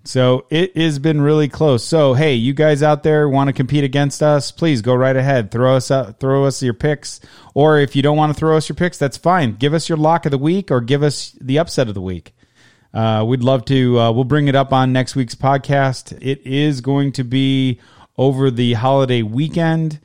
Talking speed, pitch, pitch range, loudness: 230 wpm, 140 Hz, 130-150 Hz, -16 LUFS